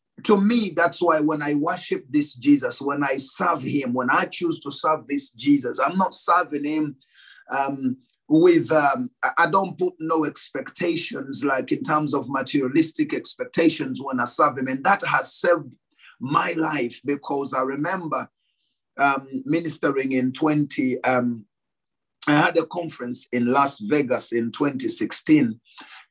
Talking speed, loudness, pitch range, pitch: 150 wpm, -23 LUFS, 135-205 Hz, 155 Hz